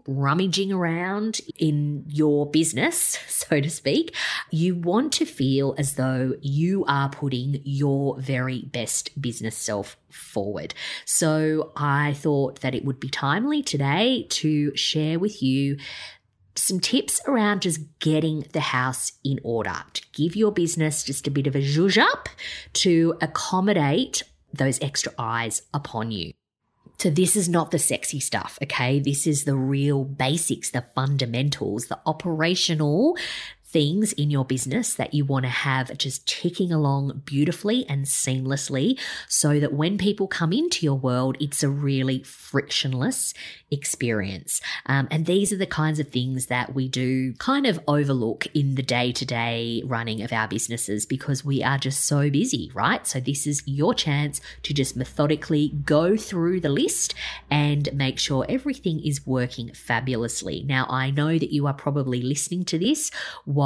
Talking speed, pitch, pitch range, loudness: 160 wpm, 145 Hz, 130-160 Hz, -24 LUFS